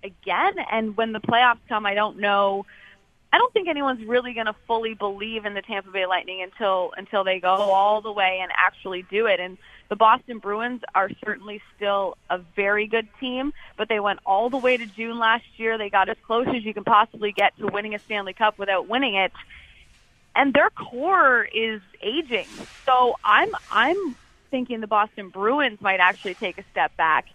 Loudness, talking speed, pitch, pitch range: -23 LUFS, 195 wpm, 215 Hz, 195-240 Hz